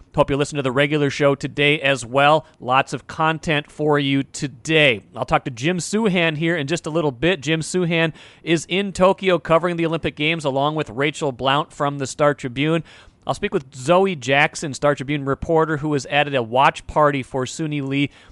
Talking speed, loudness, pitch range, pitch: 200 wpm, -20 LUFS, 140-165 Hz, 150 Hz